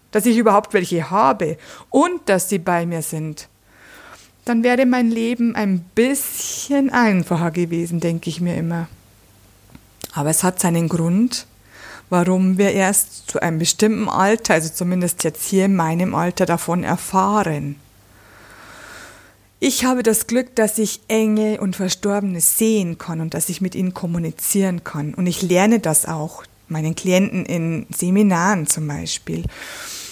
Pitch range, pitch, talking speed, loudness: 165-210 Hz, 180 Hz, 145 wpm, -18 LUFS